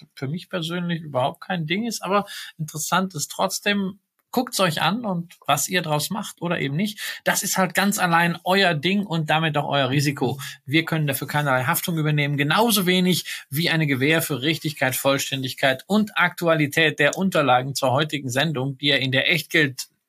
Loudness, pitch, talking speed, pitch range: -22 LUFS, 165 Hz, 185 wpm, 145-180 Hz